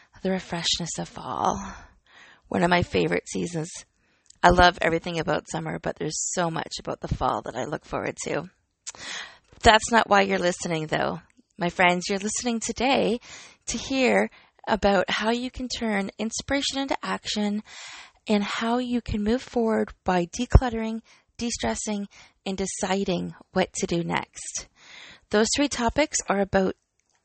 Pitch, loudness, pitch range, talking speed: 210 Hz, -25 LUFS, 185-235 Hz, 150 wpm